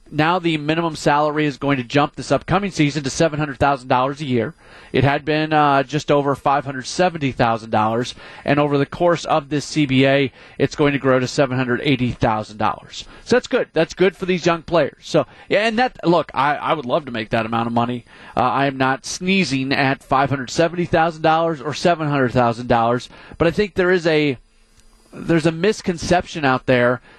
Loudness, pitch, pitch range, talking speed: -19 LUFS, 145 Hz, 130-165 Hz, 215 wpm